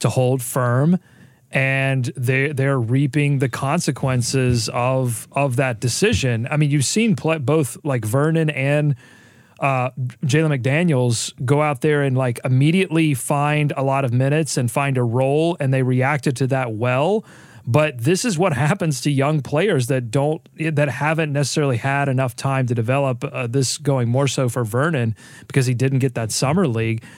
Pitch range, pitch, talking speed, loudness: 130-150 Hz, 135 Hz, 170 wpm, -19 LUFS